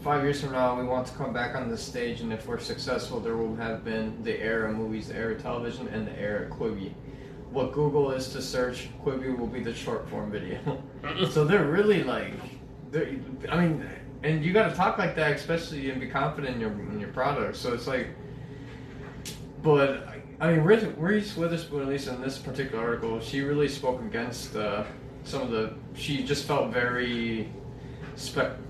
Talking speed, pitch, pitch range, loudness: 190 wpm, 135 Hz, 125-145 Hz, -29 LUFS